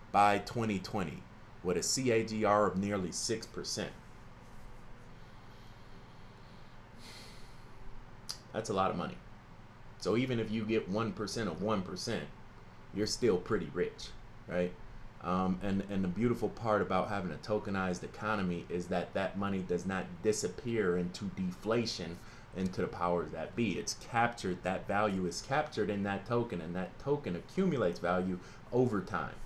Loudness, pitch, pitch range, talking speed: -35 LUFS, 105 Hz, 90-115 Hz, 135 wpm